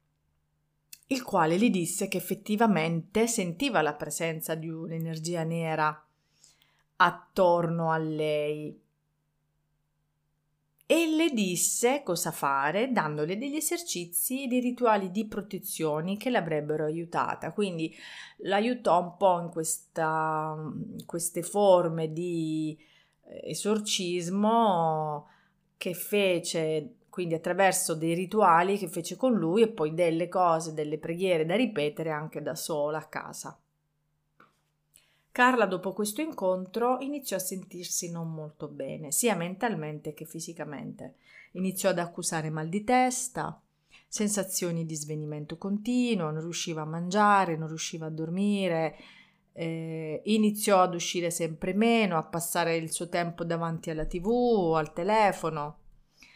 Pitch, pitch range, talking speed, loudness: 170 Hz, 155-200 Hz, 120 wpm, -28 LUFS